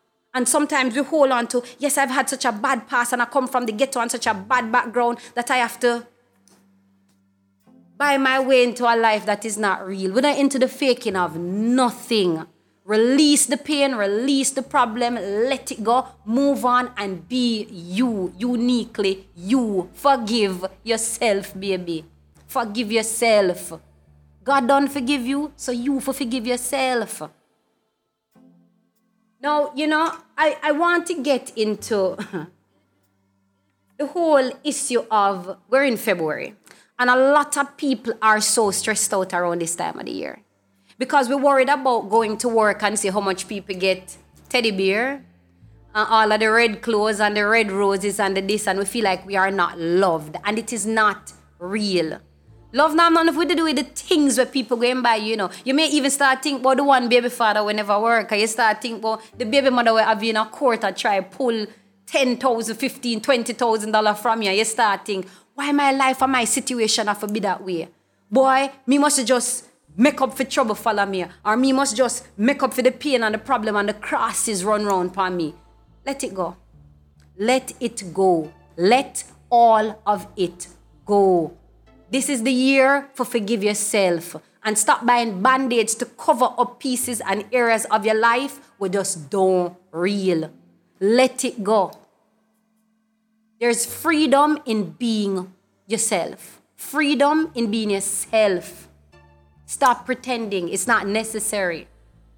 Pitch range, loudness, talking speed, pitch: 195-260 Hz, -20 LUFS, 170 wpm, 225 Hz